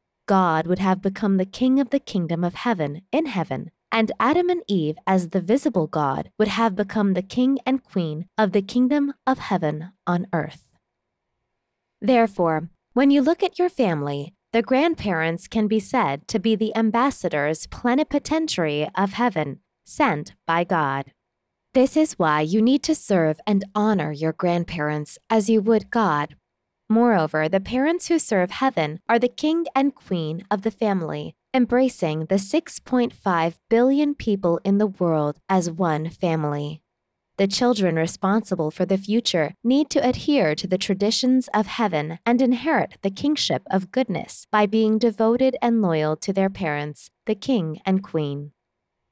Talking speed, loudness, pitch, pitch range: 160 wpm, -22 LUFS, 195 Hz, 165-245 Hz